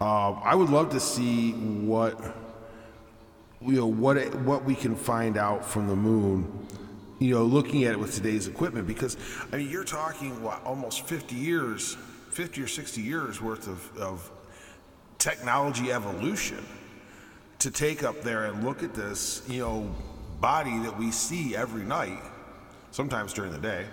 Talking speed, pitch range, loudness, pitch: 165 wpm, 105-130 Hz, -28 LUFS, 115 Hz